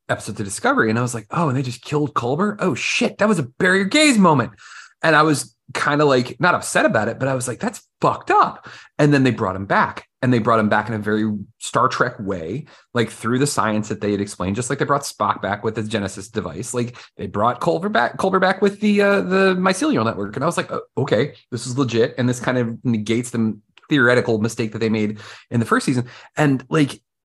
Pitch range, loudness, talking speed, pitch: 110-150 Hz, -19 LUFS, 245 wpm, 125 Hz